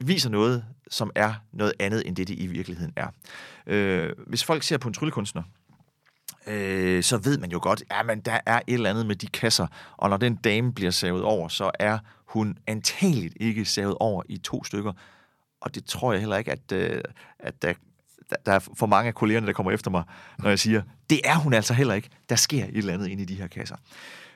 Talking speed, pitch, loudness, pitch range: 225 wpm, 110 Hz, -26 LUFS, 100-120 Hz